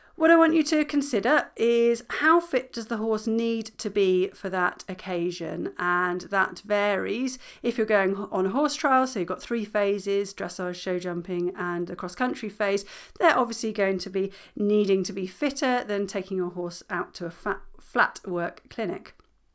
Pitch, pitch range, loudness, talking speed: 200 Hz, 185-235 Hz, -26 LUFS, 185 wpm